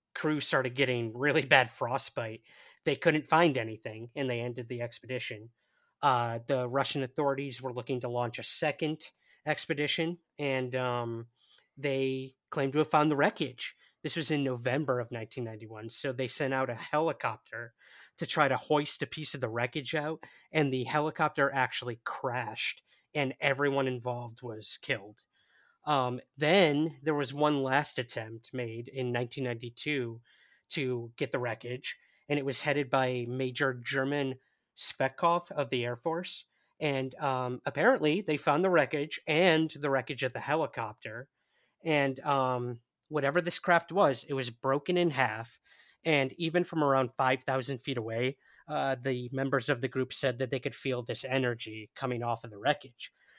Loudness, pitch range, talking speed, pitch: -31 LUFS, 125-150 Hz, 160 wpm, 135 Hz